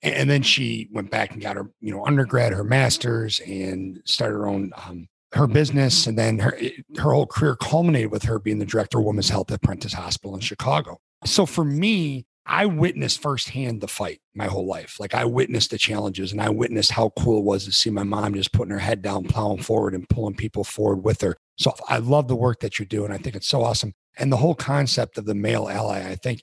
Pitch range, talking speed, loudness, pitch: 100-130 Hz, 235 wpm, -22 LUFS, 110 Hz